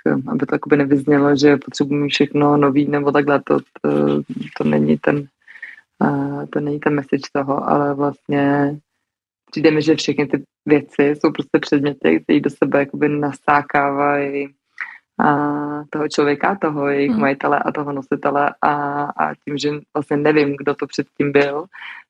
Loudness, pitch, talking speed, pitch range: -18 LUFS, 145 Hz, 145 wpm, 140-145 Hz